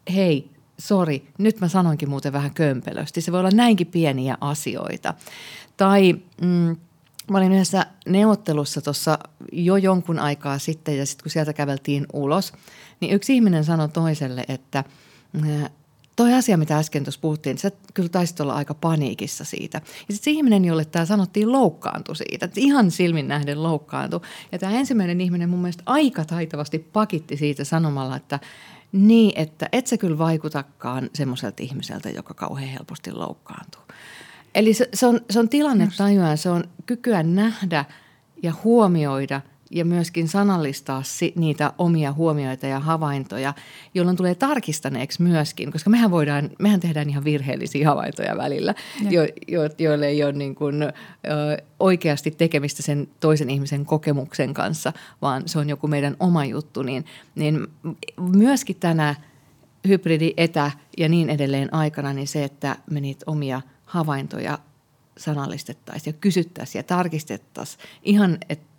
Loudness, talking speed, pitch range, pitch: -22 LUFS, 145 wpm, 145-185 Hz, 155 Hz